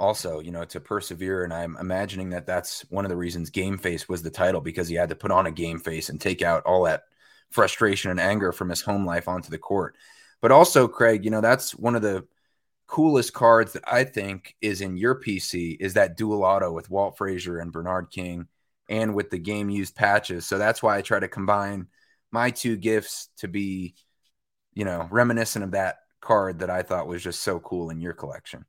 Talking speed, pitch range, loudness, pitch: 220 wpm, 85-105 Hz, -24 LUFS, 95 Hz